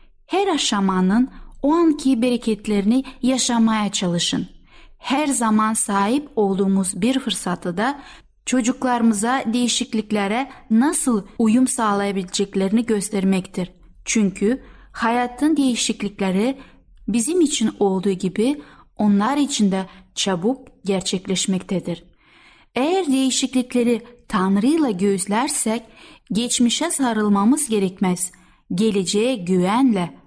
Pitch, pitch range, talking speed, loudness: 225 Hz, 200-255 Hz, 80 wpm, -20 LUFS